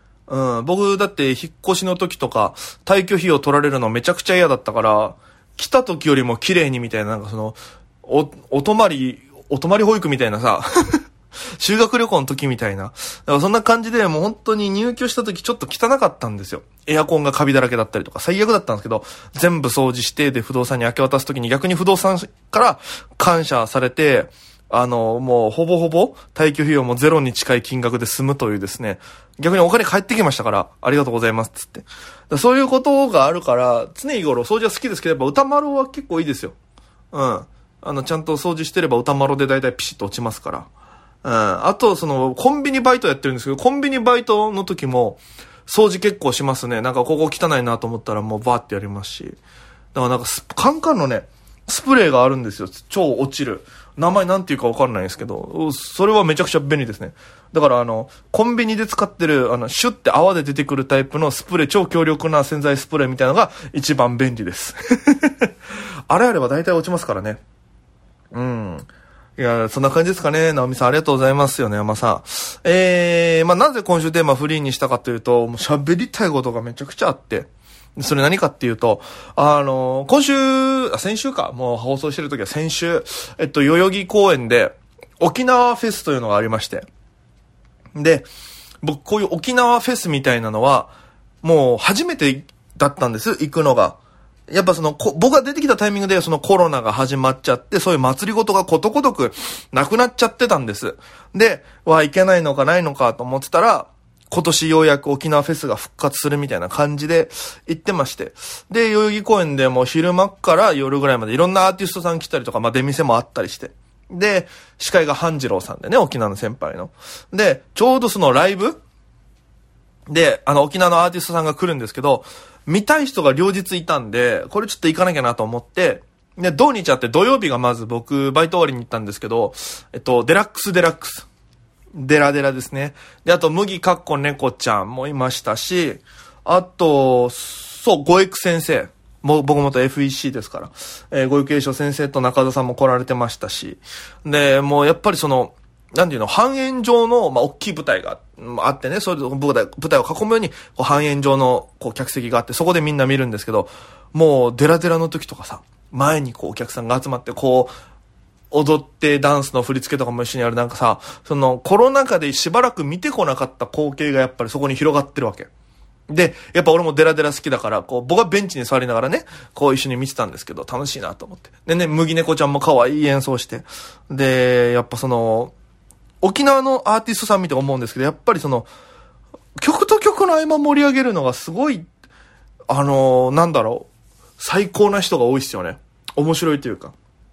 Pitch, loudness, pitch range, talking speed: 150 Hz, -17 LUFS, 130-190 Hz, 405 characters per minute